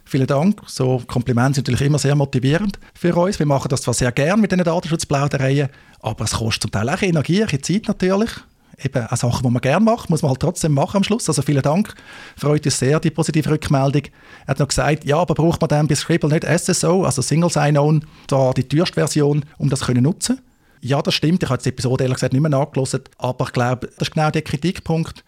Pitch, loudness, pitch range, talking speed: 145 Hz, -18 LUFS, 130-165 Hz, 225 wpm